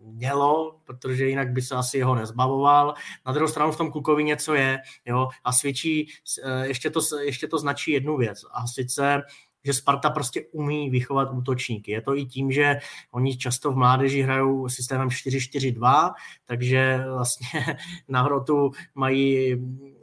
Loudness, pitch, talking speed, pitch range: -24 LUFS, 135 Hz, 155 wpm, 130-145 Hz